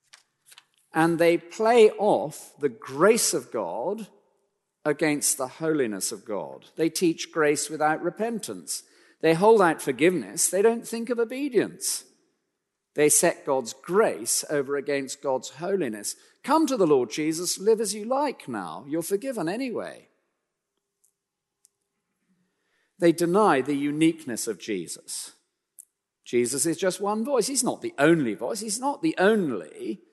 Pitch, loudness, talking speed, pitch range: 195 Hz, -25 LUFS, 135 wpm, 160-230 Hz